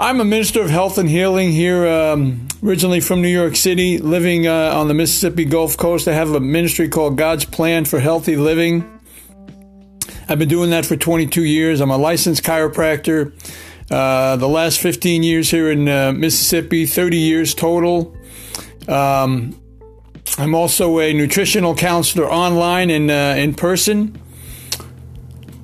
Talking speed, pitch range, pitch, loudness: 150 wpm, 150-175 Hz, 165 Hz, -15 LUFS